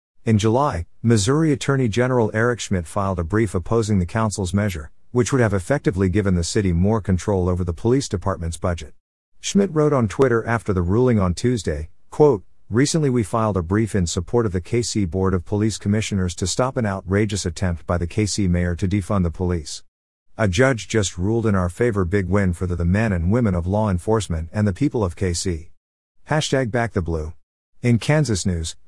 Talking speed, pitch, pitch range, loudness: 195 wpm, 100 Hz, 90-115 Hz, -21 LUFS